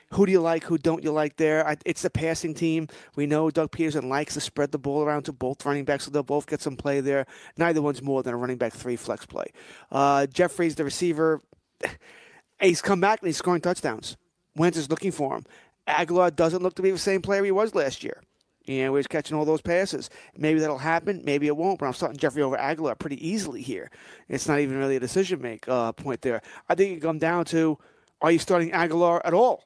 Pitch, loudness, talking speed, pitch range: 155 Hz, -25 LUFS, 235 wpm, 140-175 Hz